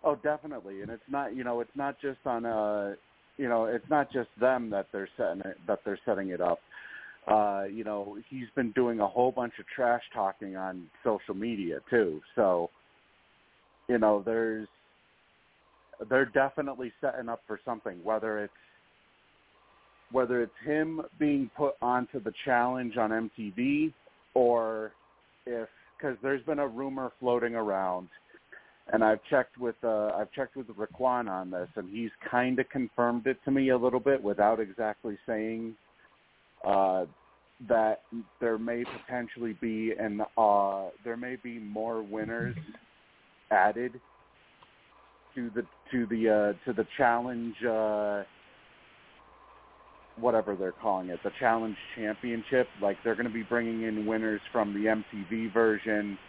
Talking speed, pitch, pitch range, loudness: 145 wpm, 115 Hz, 105-125 Hz, -31 LUFS